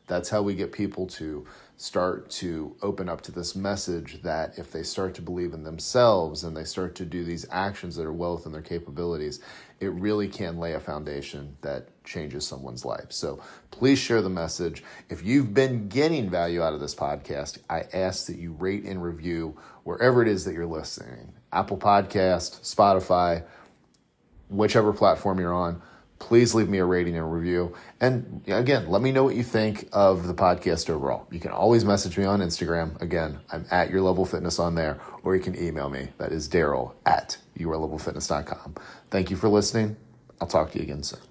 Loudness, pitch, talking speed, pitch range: -26 LUFS, 90 Hz, 190 wpm, 85-100 Hz